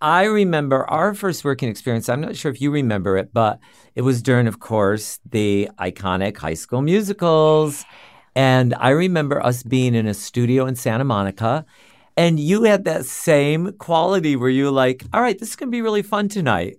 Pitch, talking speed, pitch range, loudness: 135 Hz, 195 wpm, 115-170 Hz, -19 LUFS